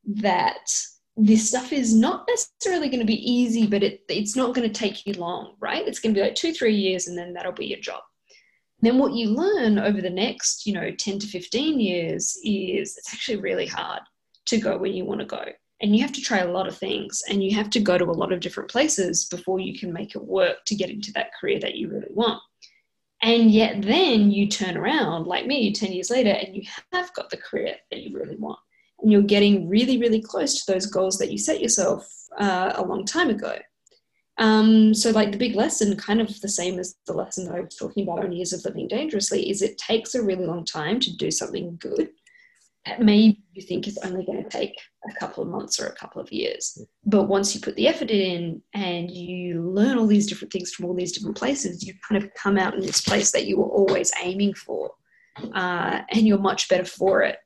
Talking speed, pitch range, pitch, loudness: 235 wpm, 190-235 Hz, 205 Hz, -23 LUFS